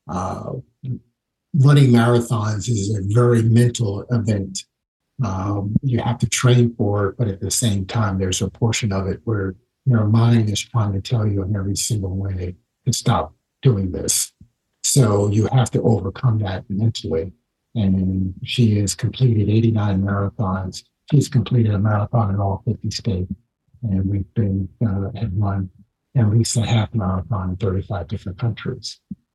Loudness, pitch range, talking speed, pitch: -20 LUFS, 95-120 Hz, 160 wpm, 105 Hz